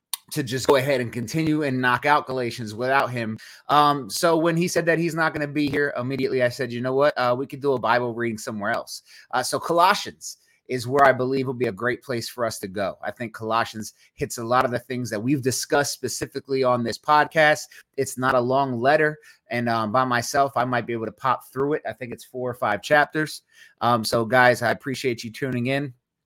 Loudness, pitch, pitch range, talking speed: -23 LUFS, 130 Hz, 120-145 Hz, 235 wpm